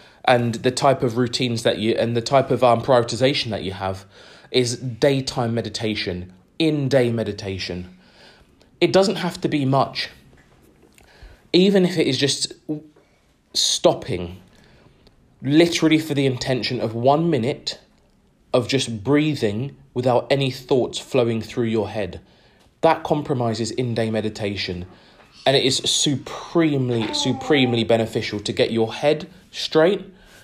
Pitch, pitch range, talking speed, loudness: 125 Hz, 110-145 Hz, 130 wpm, -21 LUFS